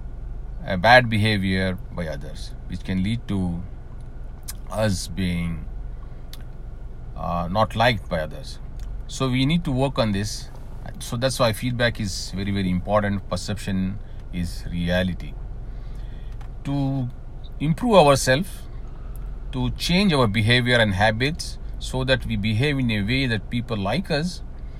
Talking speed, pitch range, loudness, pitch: 130 wpm, 95-130 Hz, -22 LUFS, 110 Hz